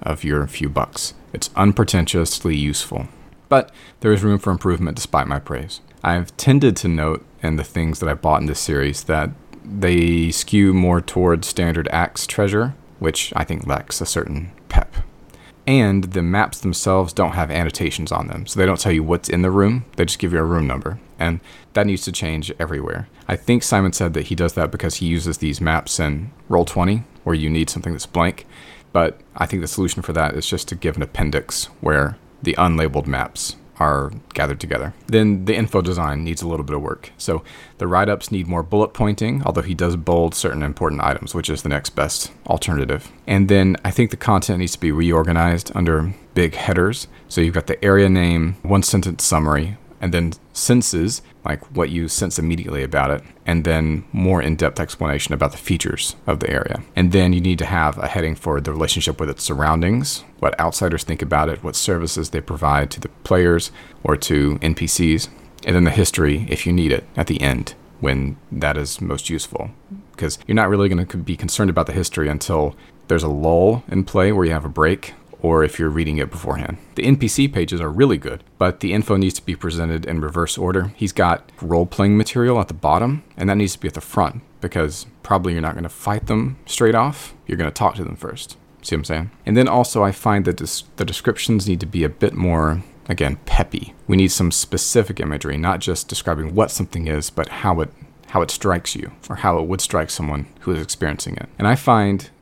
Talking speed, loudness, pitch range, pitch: 215 wpm, -19 LUFS, 80-100 Hz, 85 Hz